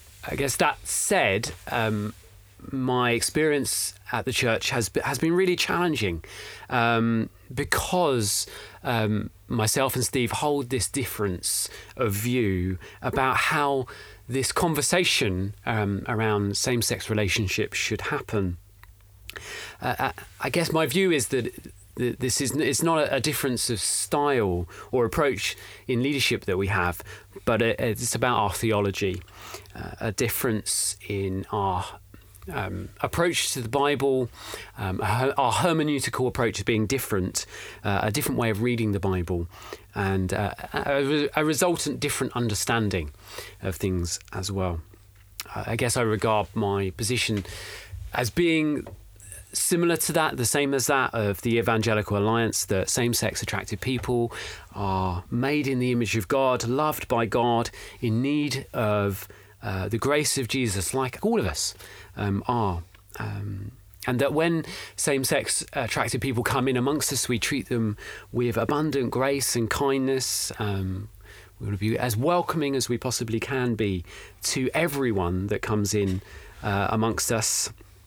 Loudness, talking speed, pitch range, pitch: -25 LUFS, 140 wpm, 100-130 Hz, 115 Hz